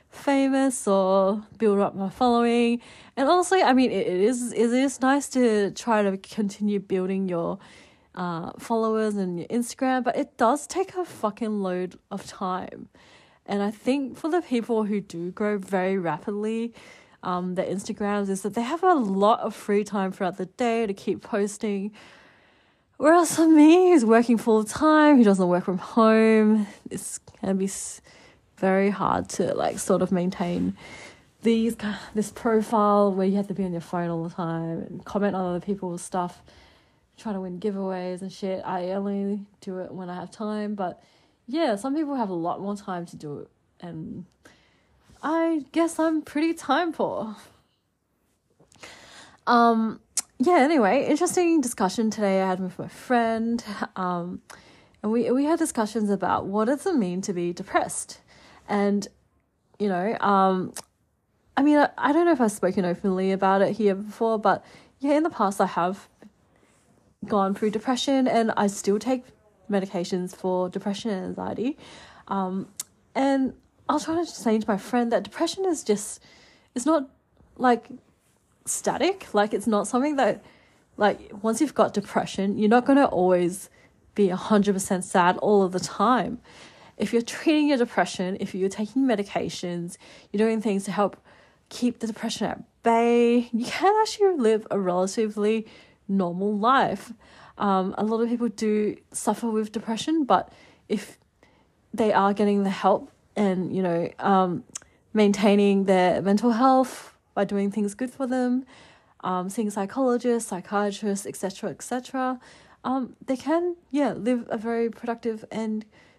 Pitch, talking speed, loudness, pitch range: 215 Hz, 160 wpm, -24 LUFS, 195-245 Hz